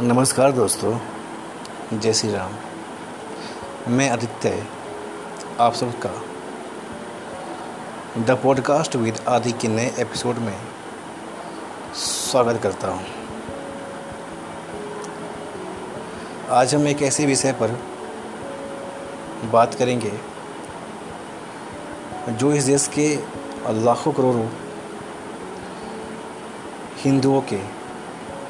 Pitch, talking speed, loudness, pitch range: 120 Hz, 75 wpm, -23 LUFS, 110-135 Hz